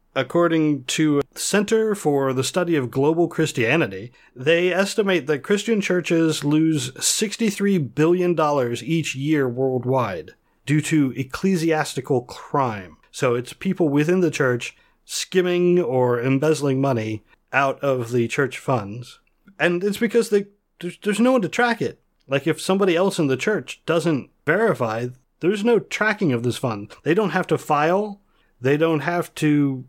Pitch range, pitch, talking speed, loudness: 135-185 Hz, 155 Hz, 150 wpm, -21 LUFS